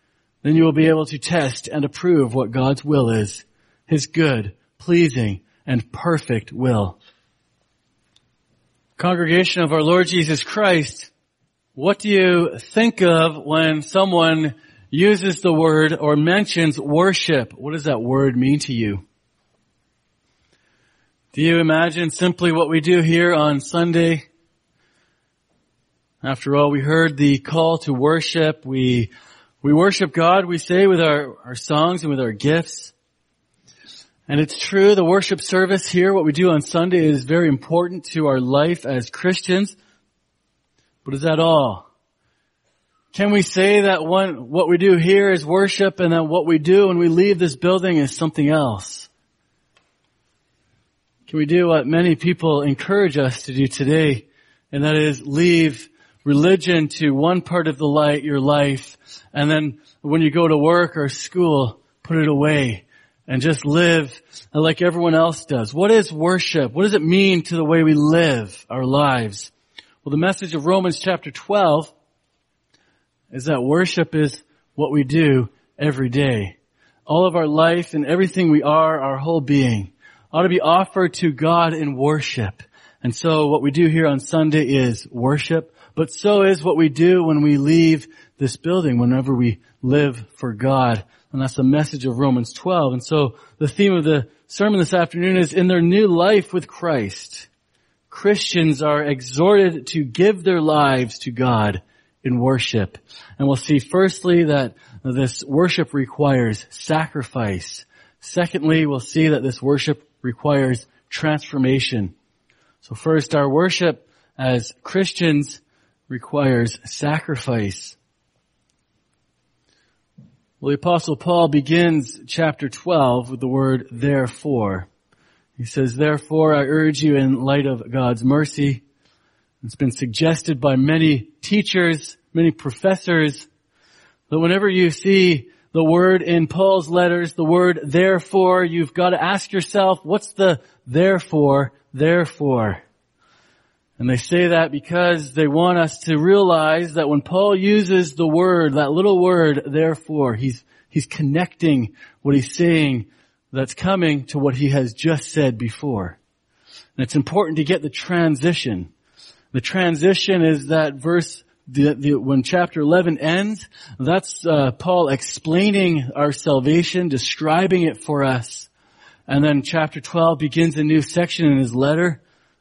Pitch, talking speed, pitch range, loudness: 155 Hz, 150 wpm, 135-175 Hz, -18 LUFS